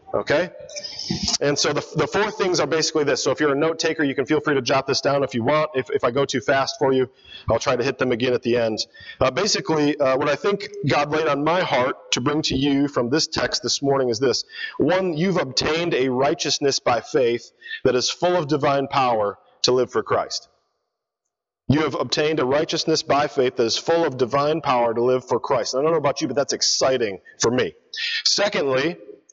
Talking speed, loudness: 230 wpm, -21 LUFS